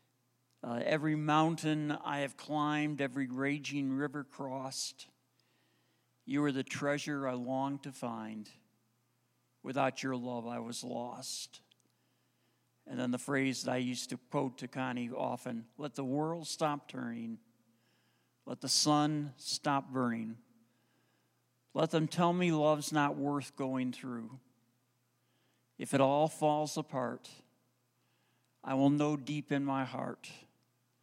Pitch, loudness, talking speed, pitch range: 135 Hz, -35 LUFS, 130 wpm, 120-145 Hz